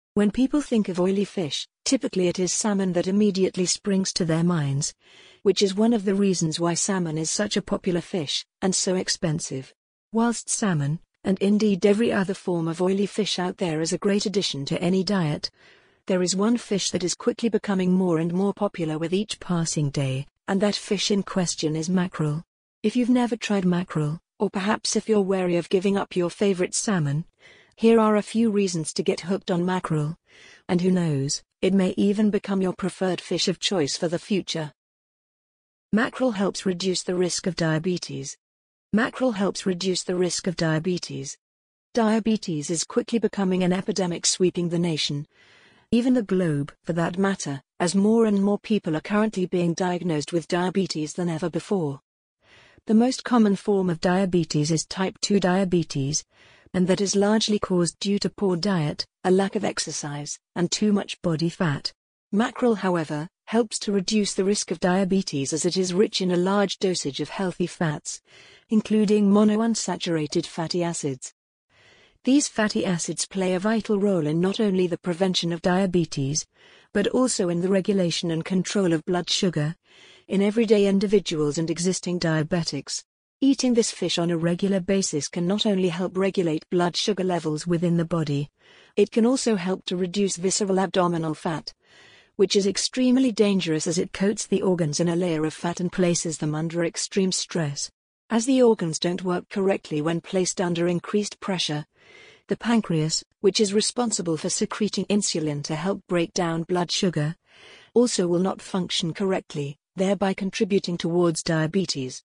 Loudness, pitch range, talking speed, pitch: -24 LUFS, 170-205 Hz, 170 wpm, 185 Hz